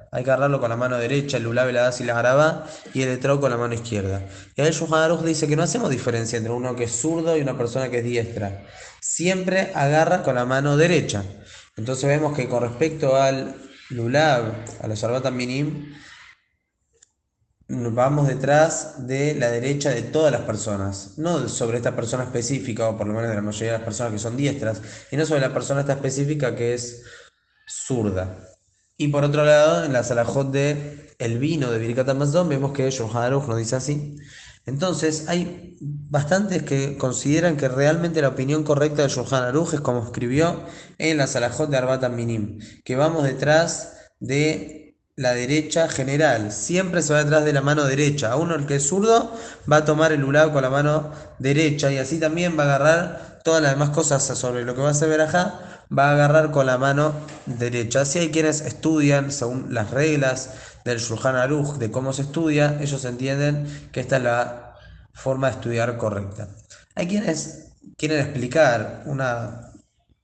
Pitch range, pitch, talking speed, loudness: 120-155 Hz, 140 Hz, 185 wpm, -22 LUFS